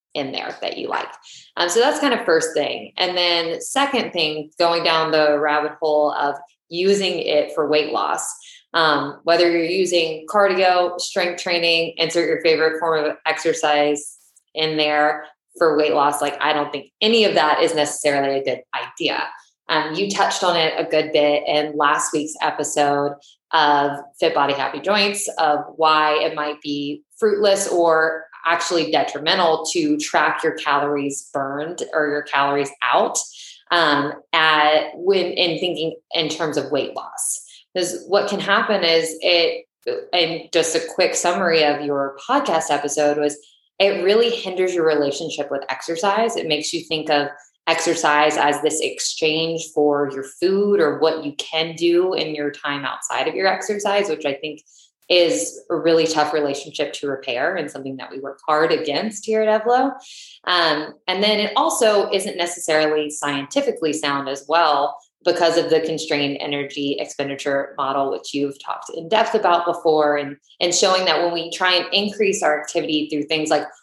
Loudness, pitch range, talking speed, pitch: -19 LUFS, 145-180 Hz, 170 wpm, 160 Hz